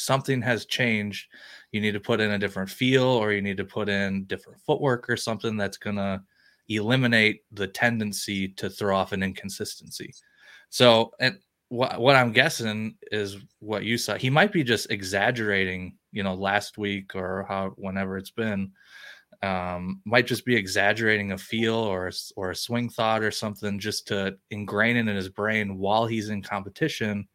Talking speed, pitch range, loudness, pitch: 175 wpm, 100-115 Hz, -25 LUFS, 105 Hz